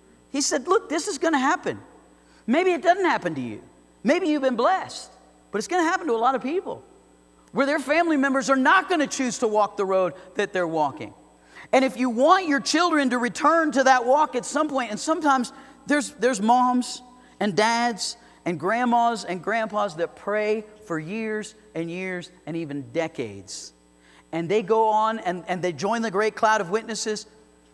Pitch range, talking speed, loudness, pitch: 200-285 Hz, 195 wpm, -23 LUFS, 235 Hz